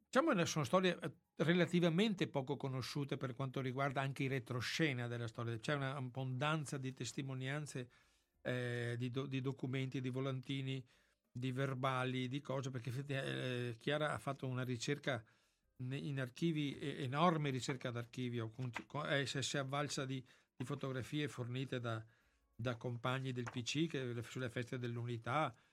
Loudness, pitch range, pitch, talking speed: -41 LUFS, 125-145 Hz, 135 Hz, 140 wpm